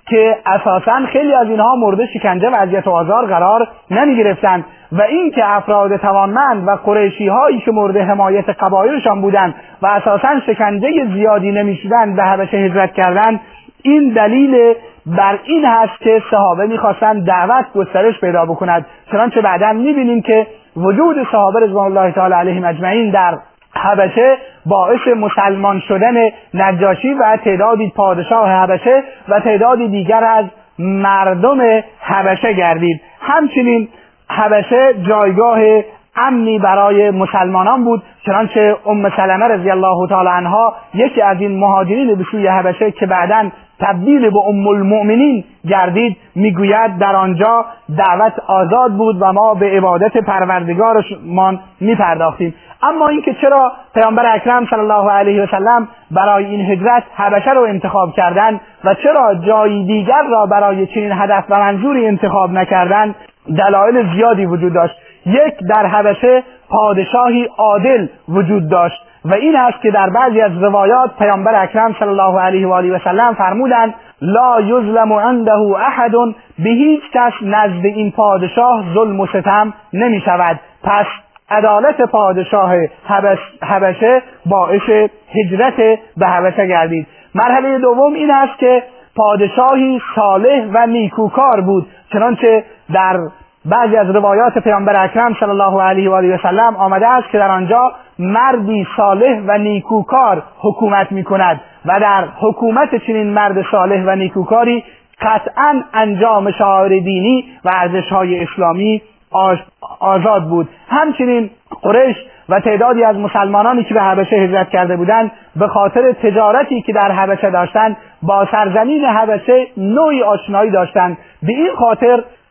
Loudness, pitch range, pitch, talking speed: -12 LUFS, 195-230 Hz, 210 Hz, 140 wpm